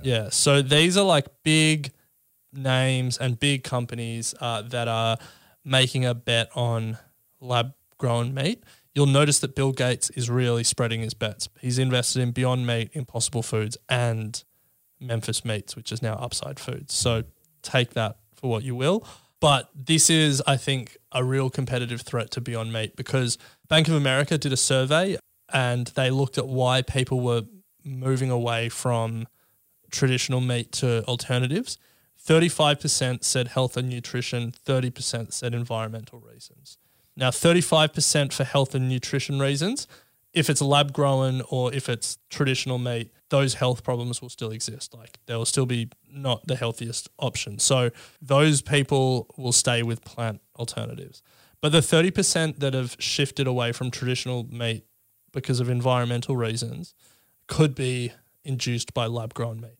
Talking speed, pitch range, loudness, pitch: 155 wpm, 120-140 Hz, -24 LUFS, 125 Hz